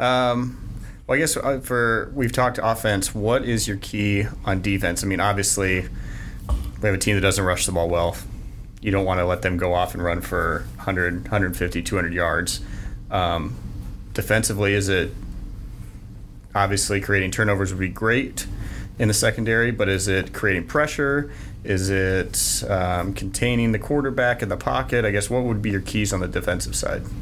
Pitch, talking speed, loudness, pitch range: 100 Hz, 175 wpm, -22 LUFS, 95-115 Hz